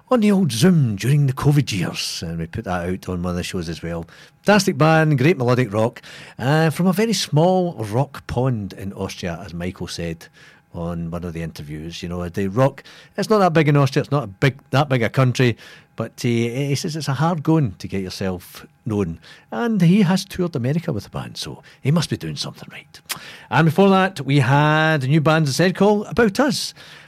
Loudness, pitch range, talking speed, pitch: -20 LUFS, 95-160 Hz, 225 wpm, 135 Hz